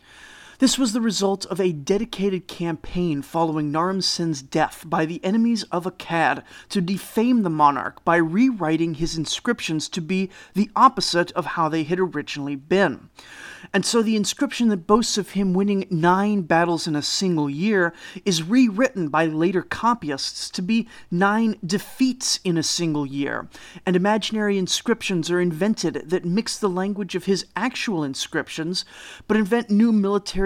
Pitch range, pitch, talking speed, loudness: 165-210 Hz, 185 Hz, 160 wpm, -22 LUFS